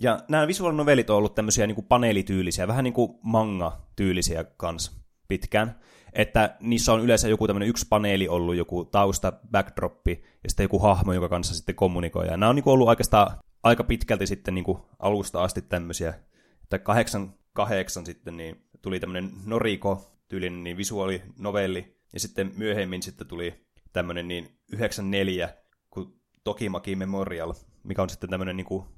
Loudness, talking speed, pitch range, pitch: -26 LUFS, 165 wpm, 90-110 Hz, 95 Hz